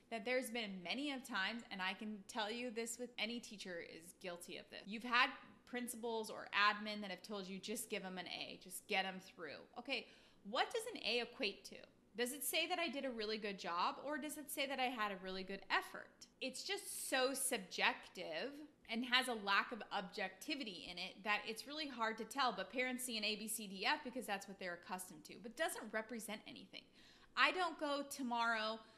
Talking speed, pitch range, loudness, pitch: 220 wpm, 205-255 Hz, -42 LUFS, 230 Hz